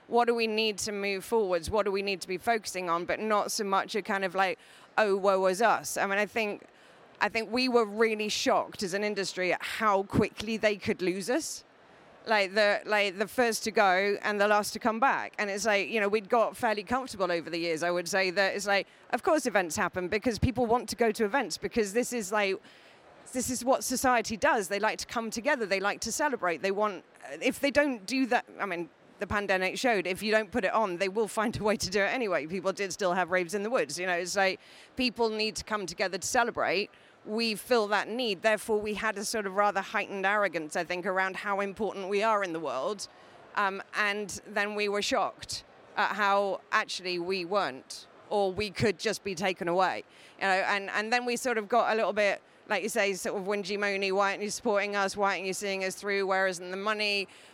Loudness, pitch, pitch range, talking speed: -29 LUFS, 205 Hz, 195-220 Hz, 240 wpm